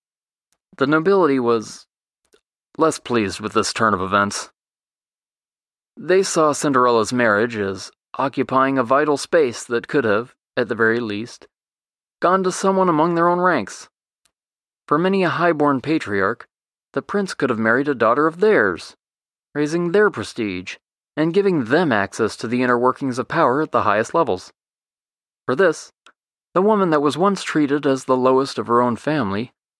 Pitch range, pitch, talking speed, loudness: 120-165 Hz, 140 Hz, 160 wpm, -19 LUFS